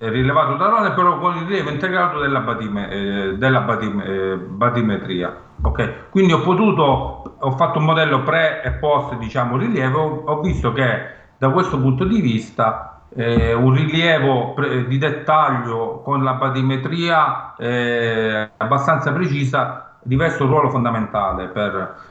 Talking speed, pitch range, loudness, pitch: 145 wpm, 115-155 Hz, -18 LUFS, 130 Hz